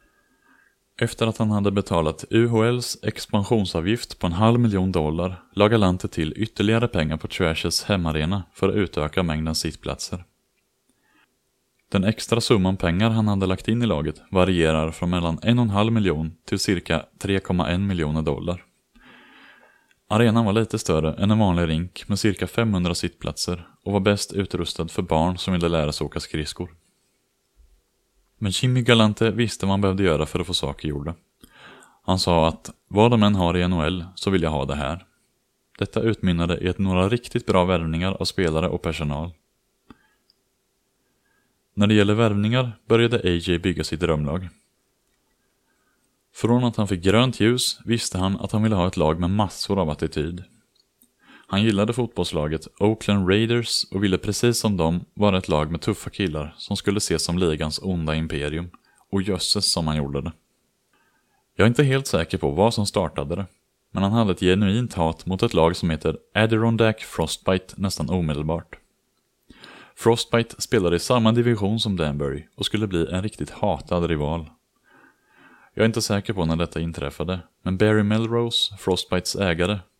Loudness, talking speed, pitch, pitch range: -22 LUFS, 165 wpm, 95 Hz, 85-110 Hz